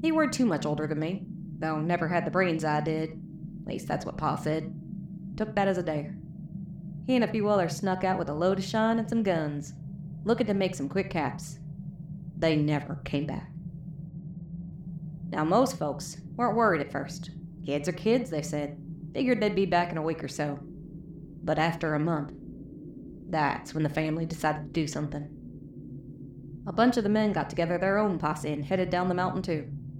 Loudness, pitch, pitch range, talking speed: -29 LUFS, 165 Hz, 155-185 Hz, 200 wpm